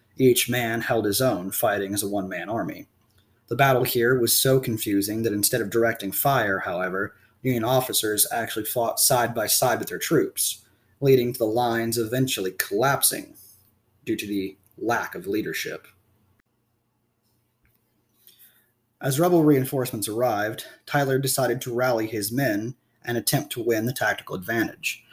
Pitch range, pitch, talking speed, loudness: 110-125 Hz, 115 Hz, 150 wpm, -23 LUFS